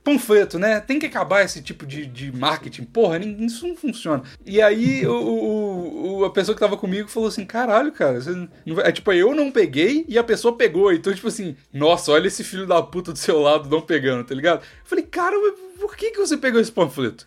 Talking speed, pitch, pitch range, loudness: 225 wpm, 210 Hz, 165-270 Hz, -20 LUFS